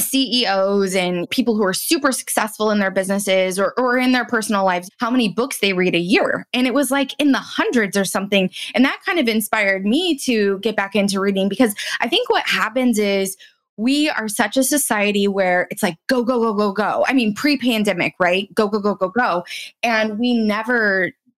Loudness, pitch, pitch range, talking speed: -18 LUFS, 215 Hz, 195-250 Hz, 210 wpm